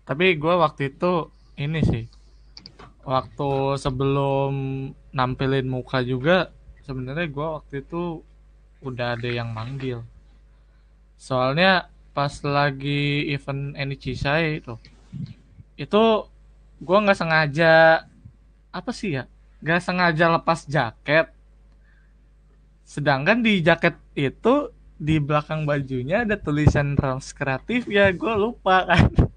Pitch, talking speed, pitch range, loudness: 145 Hz, 105 wpm, 135-170 Hz, -22 LUFS